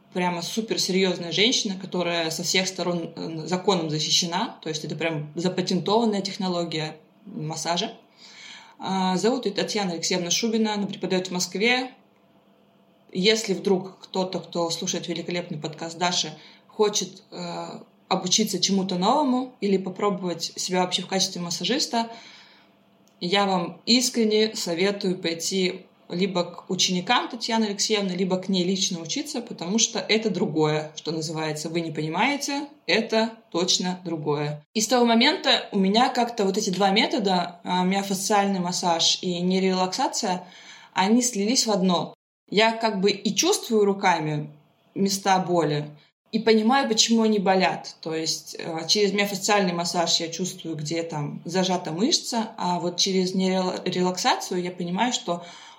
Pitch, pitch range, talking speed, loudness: 185 Hz, 175-215 Hz, 135 wpm, -24 LUFS